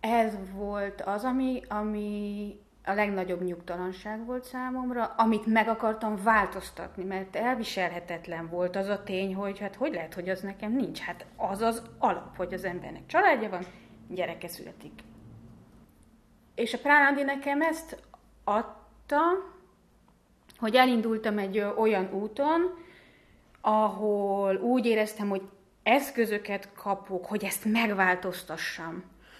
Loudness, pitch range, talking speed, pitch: -29 LUFS, 190-230 Hz, 120 wpm, 210 Hz